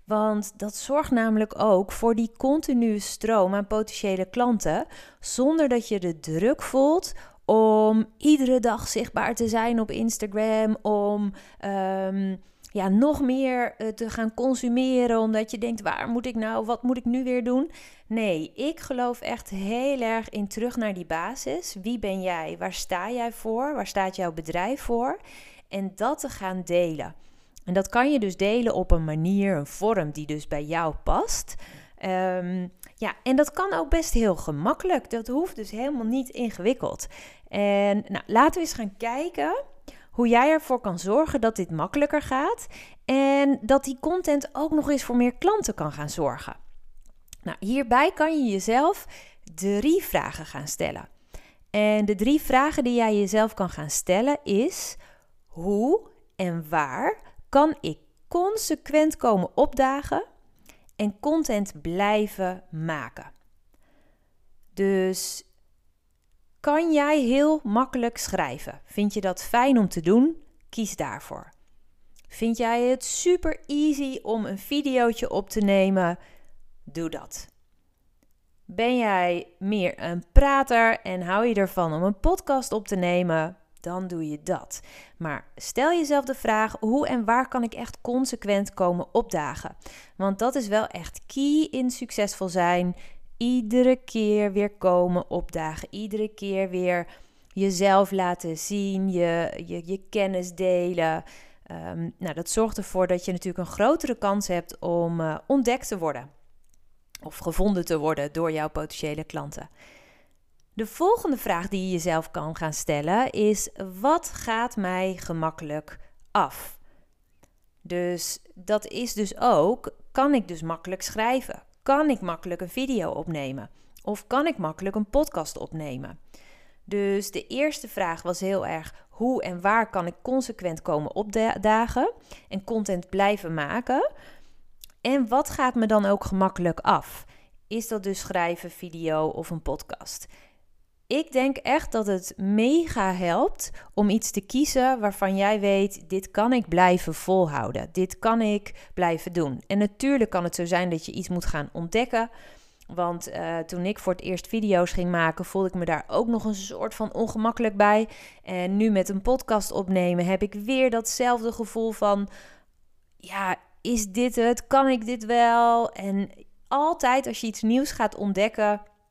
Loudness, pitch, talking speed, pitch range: -25 LUFS, 210 Hz, 155 wpm, 180-250 Hz